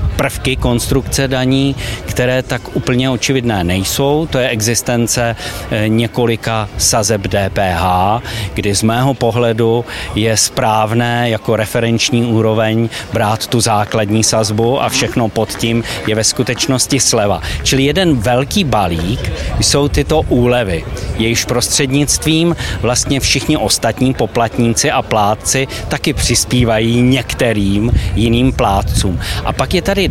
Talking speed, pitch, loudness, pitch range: 120 wpm, 115 Hz, -14 LUFS, 105-125 Hz